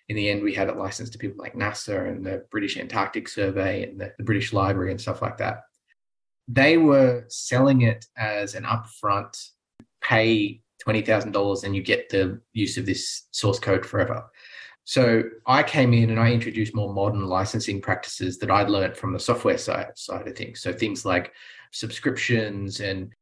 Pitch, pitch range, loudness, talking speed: 110 Hz, 100-115 Hz, -24 LUFS, 180 wpm